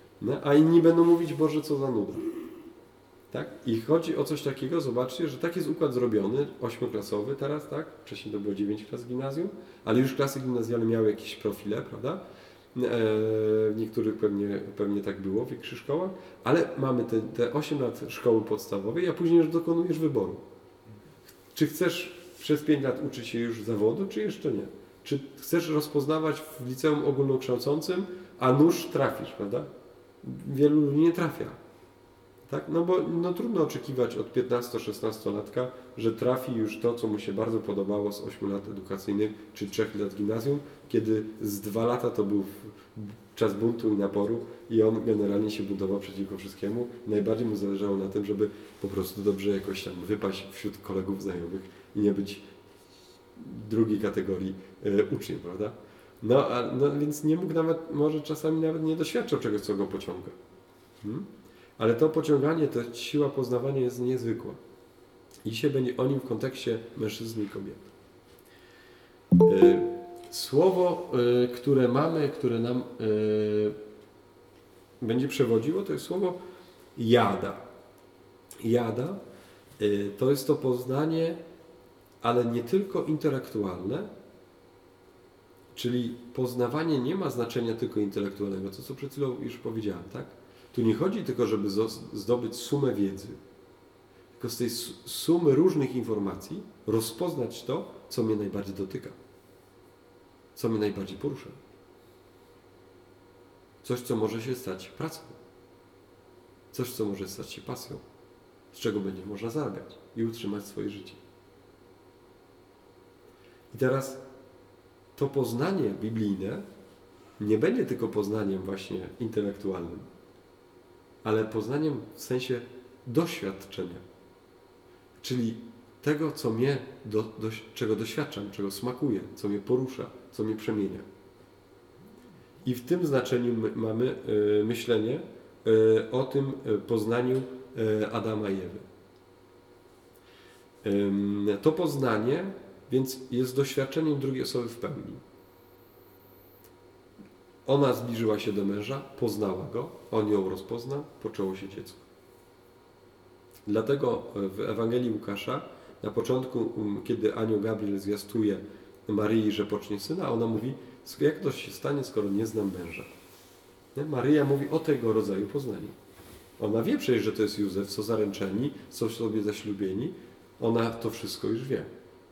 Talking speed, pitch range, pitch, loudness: 130 wpm, 105-135 Hz, 115 Hz, -29 LUFS